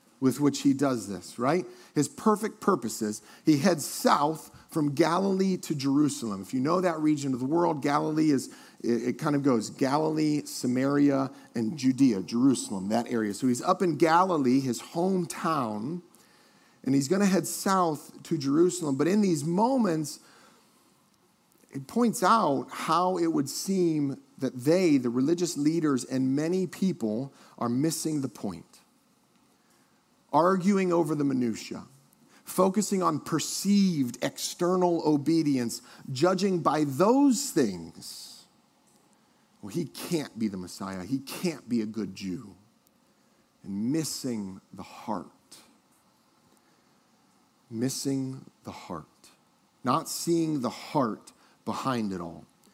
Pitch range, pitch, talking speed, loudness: 130-175 Hz, 150 Hz, 130 wpm, -27 LUFS